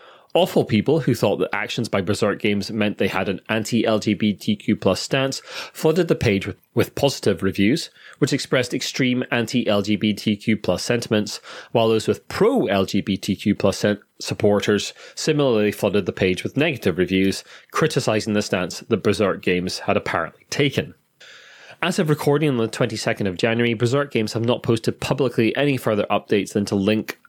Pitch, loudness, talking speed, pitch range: 110 Hz, -21 LUFS, 155 wpm, 100-125 Hz